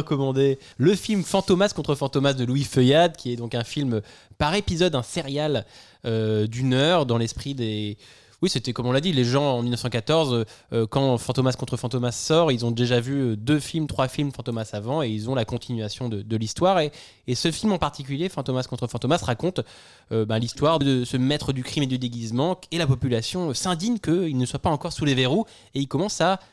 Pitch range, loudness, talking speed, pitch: 120-155 Hz, -24 LUFS, 215 wpm, 130 Hz